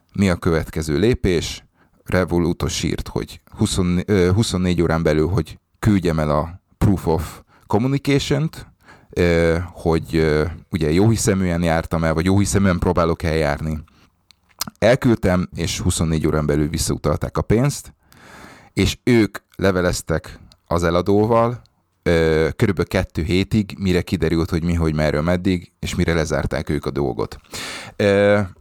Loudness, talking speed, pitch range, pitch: -19 LUFS, 130 wpm, 80-100 Hz, 90 Hz